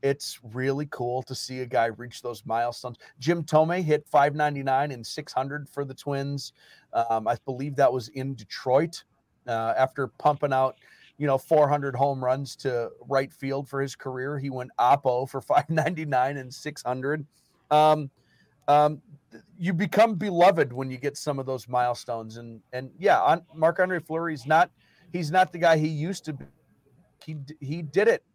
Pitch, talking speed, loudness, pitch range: 140 Hz, 165 wpm, -26 LUFS, 130-155 Hz